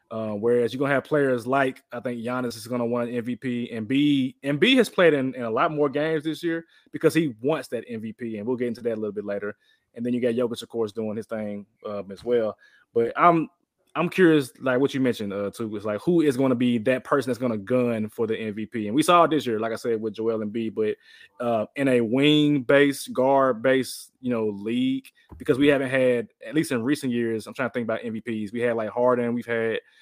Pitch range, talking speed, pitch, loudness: 115-140 Hz, 250 wpm, 120 Hz, -24 LUFS